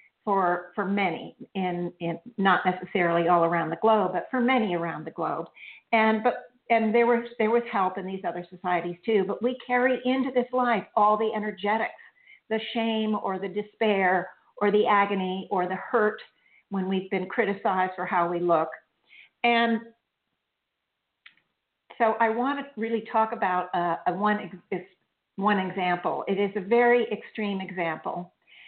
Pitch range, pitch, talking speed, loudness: 185-230 Hz, 205 Hz, 160 wpm, -26 LUFS